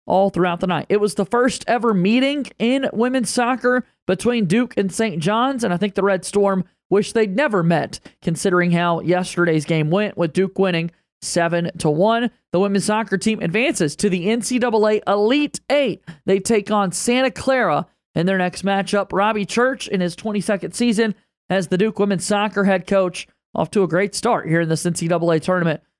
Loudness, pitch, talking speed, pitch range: -19 LUFS, 200 Hz, 185 wpm, 180-225 Hz